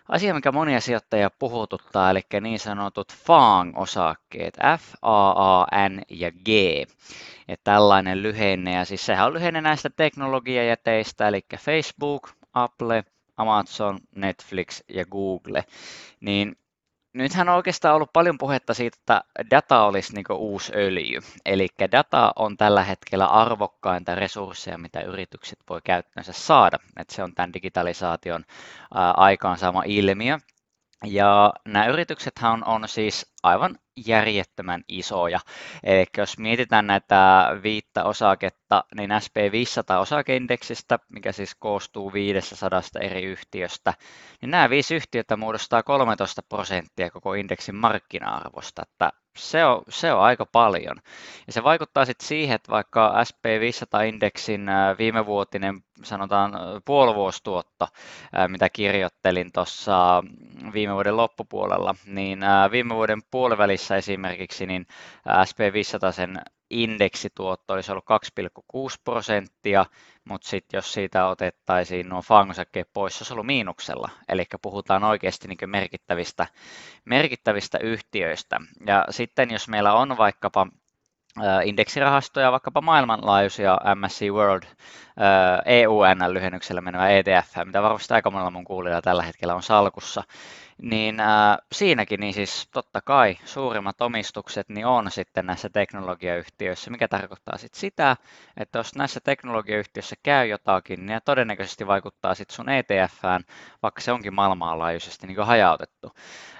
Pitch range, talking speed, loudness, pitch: 95-115 Hz, 120 wpm, -22 LUFS, 100 Hz